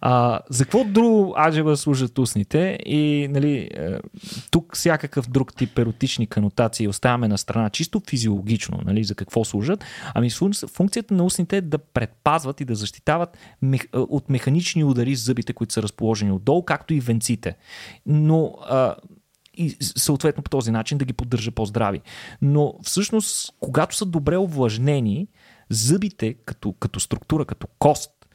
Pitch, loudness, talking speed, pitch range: 135 Hz, -22 LUFS, 145 wpm, 115-155 Hz